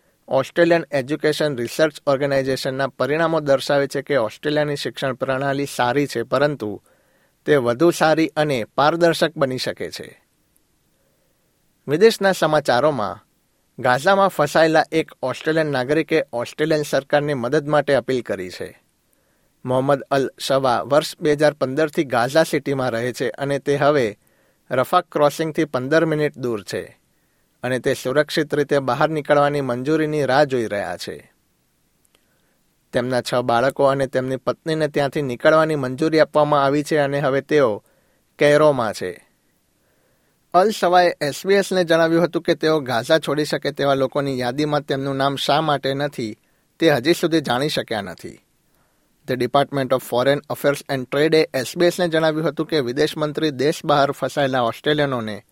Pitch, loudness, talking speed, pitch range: 145 Hz, -19 LUFS, 135 wpm, 135-155 Hz